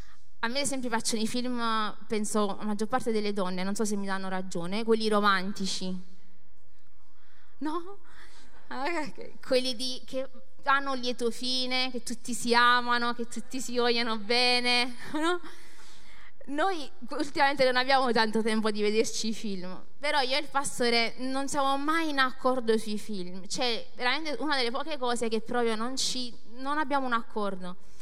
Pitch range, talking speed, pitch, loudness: 210-260 Hz, 160 wpm, 240 Hz, -29 LUFS